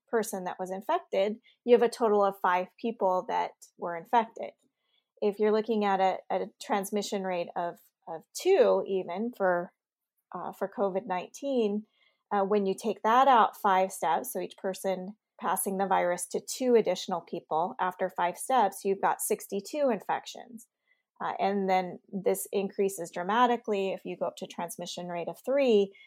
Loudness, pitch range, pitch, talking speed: -29 LUFS, 185-230 Hz, 200 Hz, 160 wpm